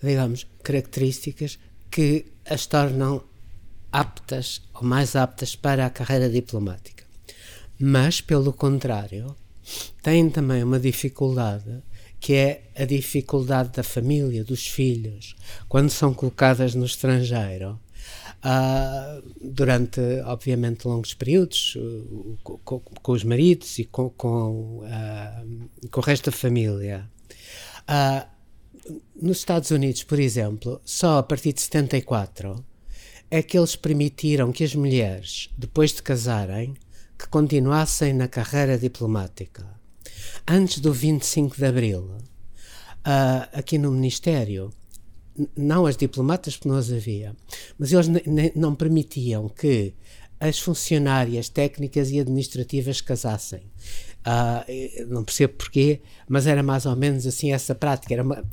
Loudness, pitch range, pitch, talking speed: -23 LUFS, 110-140 Hz, 130 Hz, 125 wpm